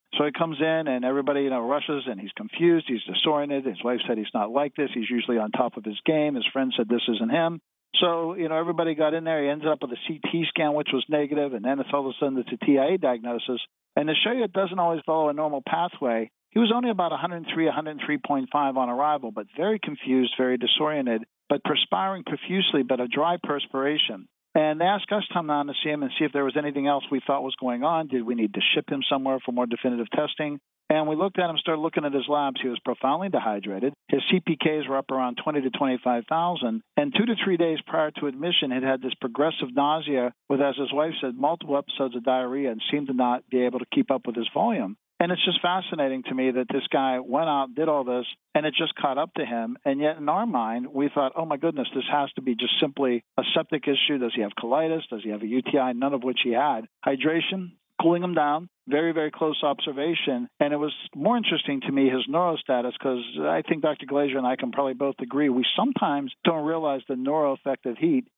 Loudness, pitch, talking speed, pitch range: -25 LUFS, 145 Hz, 240 wpm, 130-160 Hz